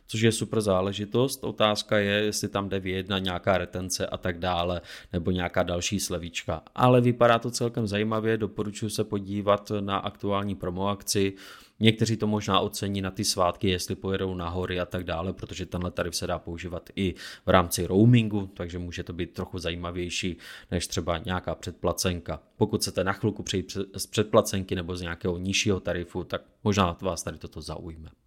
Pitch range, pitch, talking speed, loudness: 90-105 Hz, 95 Hz, 175 wpm, -27 LUFS